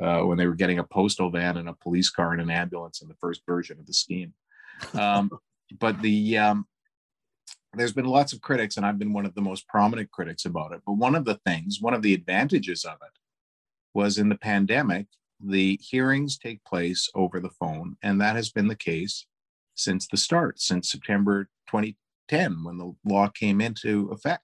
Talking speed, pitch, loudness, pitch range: 200 wpm, 100 Hz, -26 LUFS, 90-105 Hz